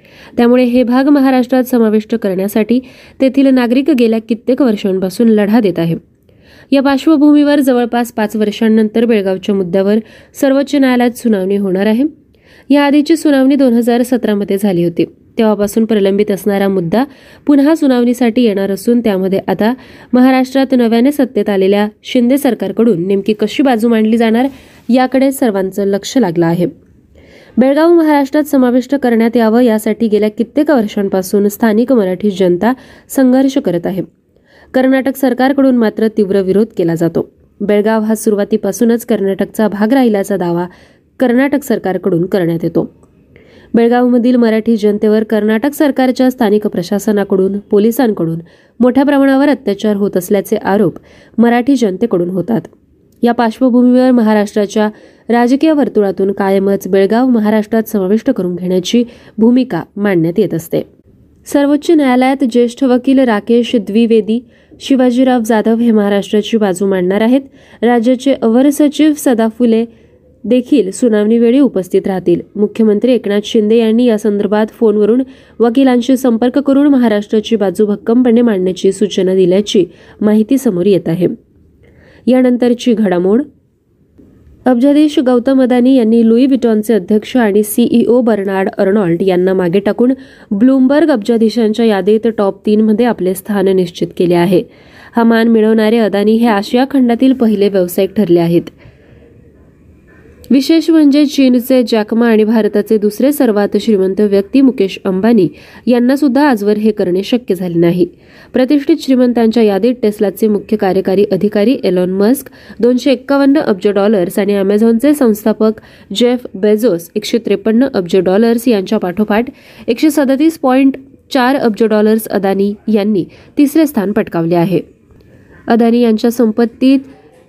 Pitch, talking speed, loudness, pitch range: 225 Hz, 125 wpm, -11 LUFS, 205-255 Hz